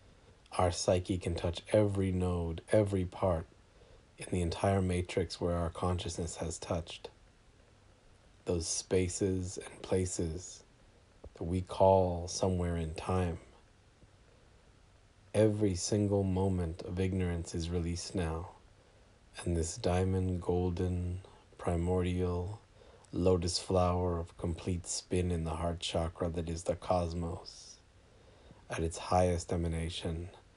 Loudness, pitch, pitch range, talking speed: -34 LUFS, 90 Hz, 85-95 Hz, 110 wpm